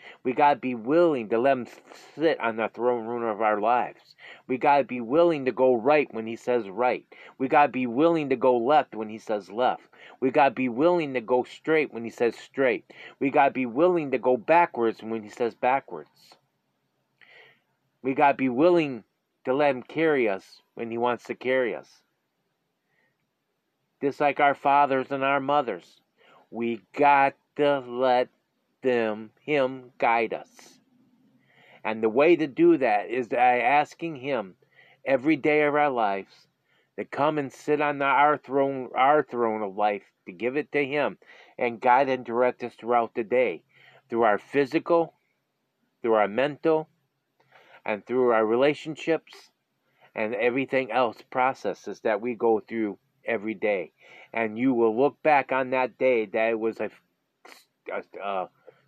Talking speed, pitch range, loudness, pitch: 165 wpm, 115-145 Hz, -25 LUFS, 130 Hz